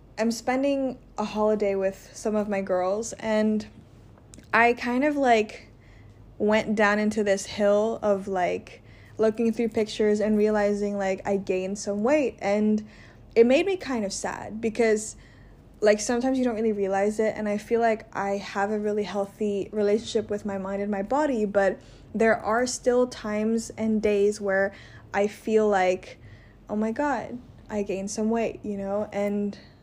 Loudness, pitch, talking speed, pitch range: -25 LUFS, 210 Hz, 165 wpm, 200-225 Hz